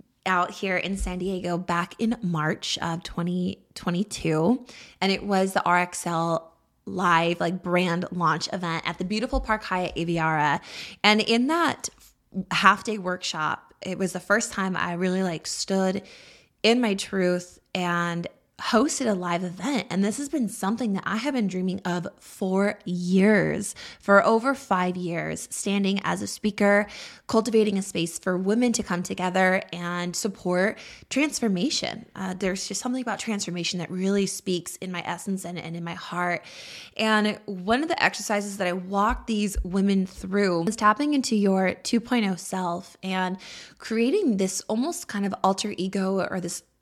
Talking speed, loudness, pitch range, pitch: 160 wpm, -25 LUFS, 180-215 Hz, 190 Hz